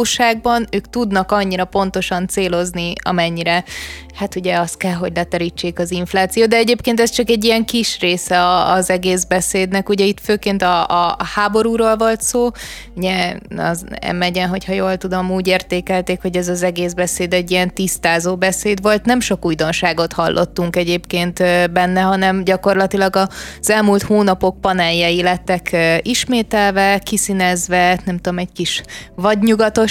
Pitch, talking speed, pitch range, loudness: 185 Hz, 140 wpm, 180-205 Hz, -16 LUFS